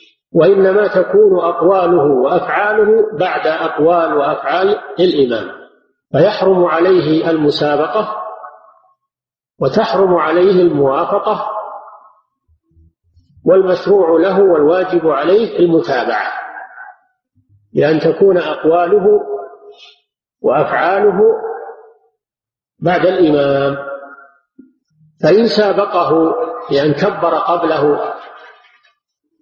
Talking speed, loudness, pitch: 65 wpm, -13 LUFS, 190 Hz